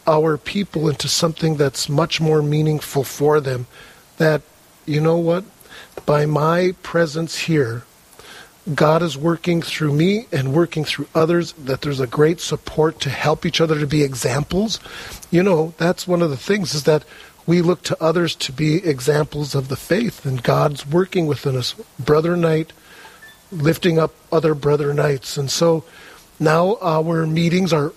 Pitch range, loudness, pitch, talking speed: 145-170 Hz, -19 LUFS, 155 Hz, 165 wpm